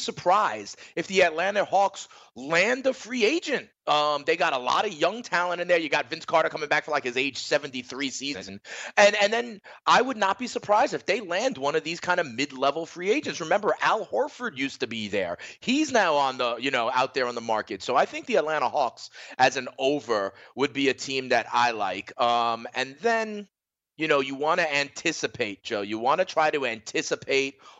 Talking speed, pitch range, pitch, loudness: 215 wpm, 135-200 Hz, 155 Hz, -25 LUFS